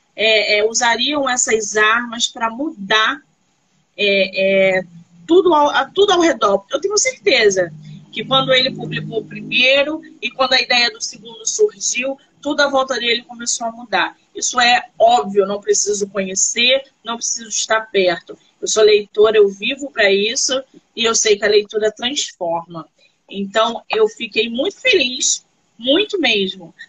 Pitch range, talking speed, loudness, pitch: 205-270 Hz, 150 wpm, -16 LUFS, 225 Hz